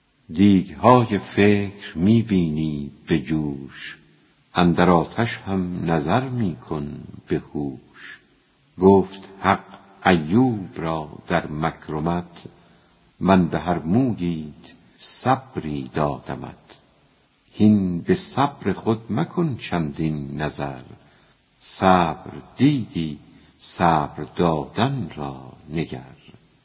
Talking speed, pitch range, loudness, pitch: 85 wpm, 75-100 Hz, -22 LUFS, 85 Hz